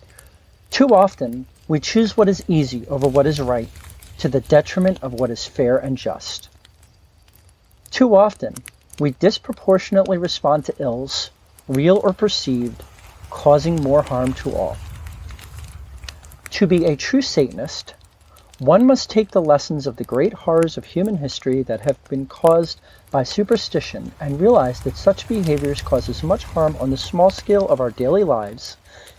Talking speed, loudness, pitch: 150 wpm, -18 LUFS, 140 Hz